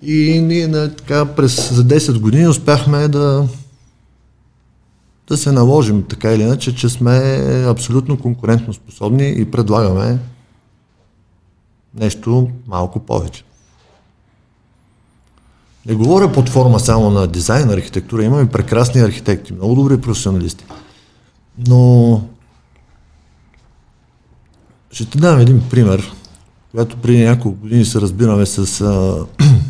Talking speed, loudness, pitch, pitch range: 105 wpm, -13 LUFS, 115 Hz, 100-130 Hz